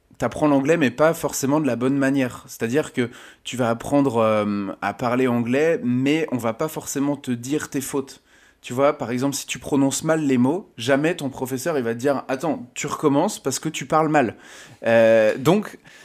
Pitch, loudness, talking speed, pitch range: 135 Hz, -21 LUFS, 200 wpm, 125-145 Hz